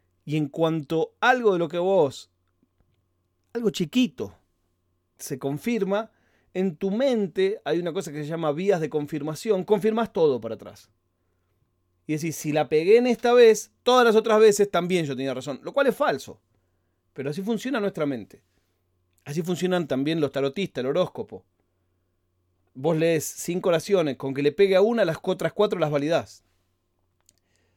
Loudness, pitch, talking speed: -24 LUFS, 150 Hz, 160 wpm